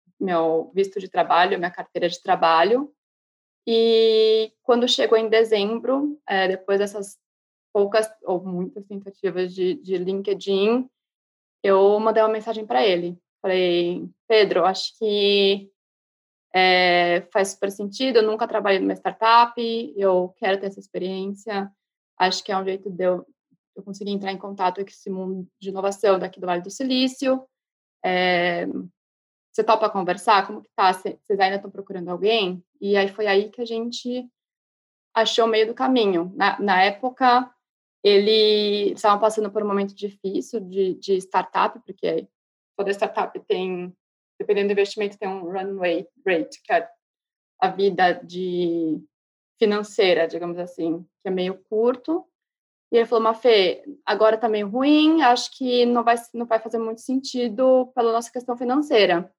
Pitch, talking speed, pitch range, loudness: 205 Hz, 155 wpm, 185-230 Hz, -22 LUFS